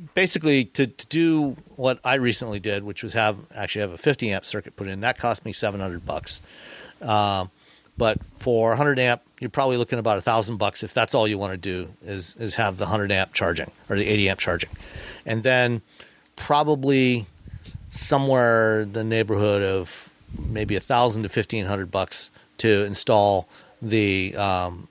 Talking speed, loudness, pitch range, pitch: 180 wpm, -23 LUFS, 100-120 Hz, 110 Hz